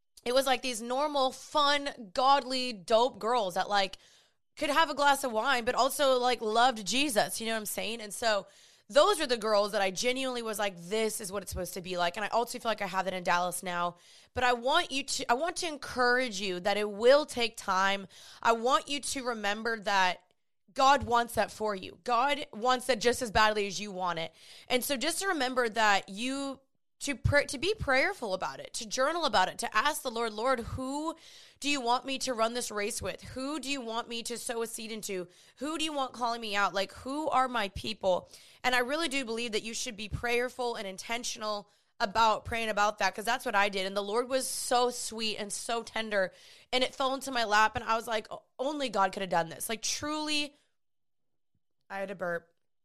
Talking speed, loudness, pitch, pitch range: 225 wpm, -30 LUFS, 235 Hz, 205-265 Hz